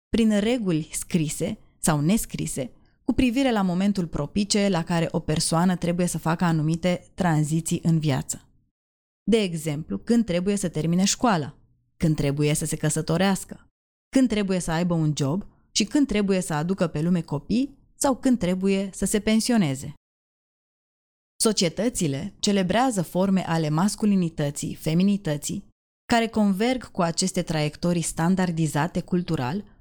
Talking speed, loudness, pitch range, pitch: 135 wpm, -24 LUFS, 160-205 Hz, 180 Hz